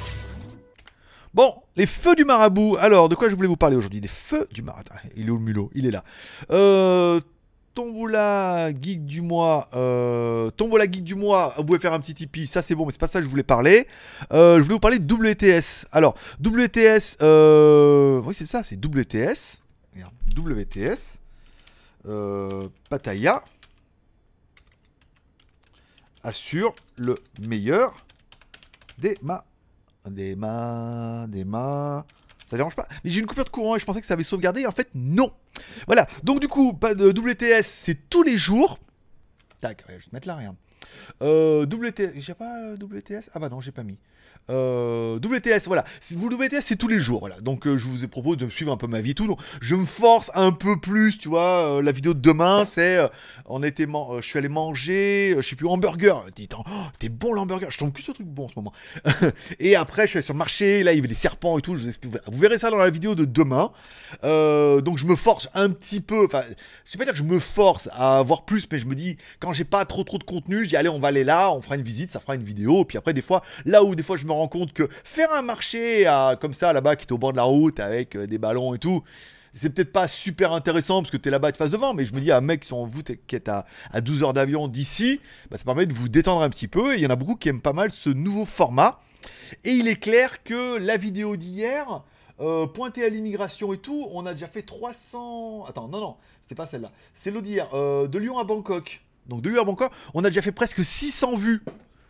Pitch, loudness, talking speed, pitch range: 165 Hz, -21 LUFS, 235 wpm, 130-205 Hz